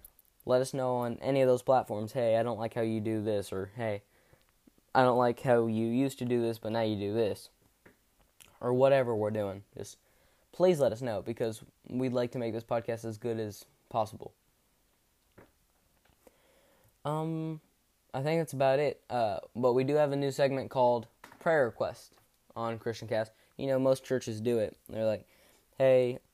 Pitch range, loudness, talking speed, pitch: 110-130 Hz, -31 LUFS, 185 wpm, 120 Hz